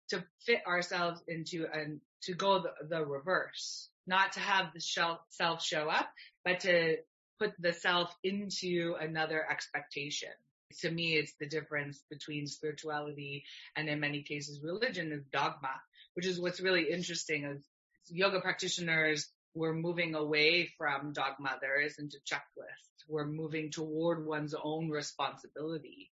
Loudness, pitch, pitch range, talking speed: -35 LUFS, 160 Hz, 150-175 Hz, 140 wpm